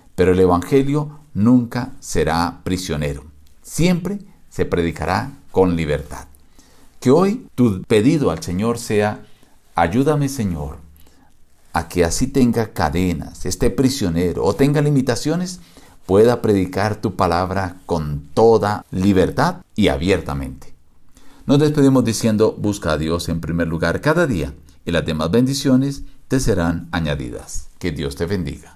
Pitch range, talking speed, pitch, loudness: 80-125 Hz, 125 wpm, 95 Hz, -19 LUFS